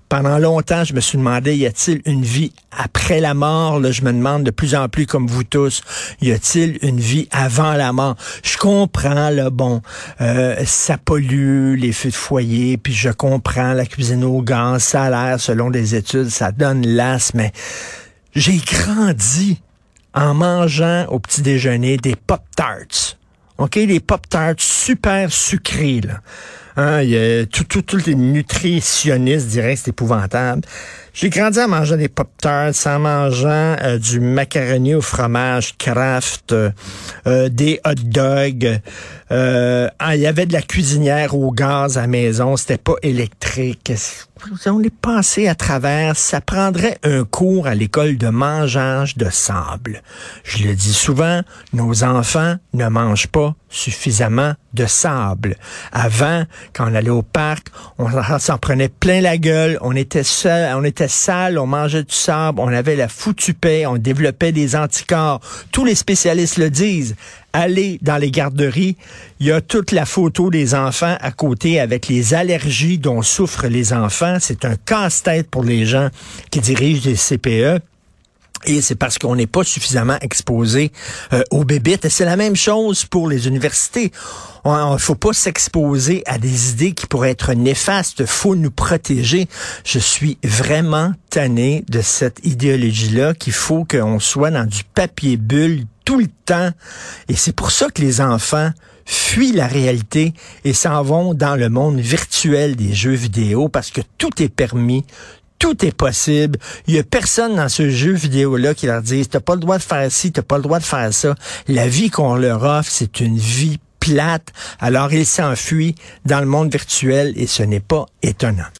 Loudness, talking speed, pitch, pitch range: -16 LUFS, 175 wpm, 140 Hz, 125-160 Hz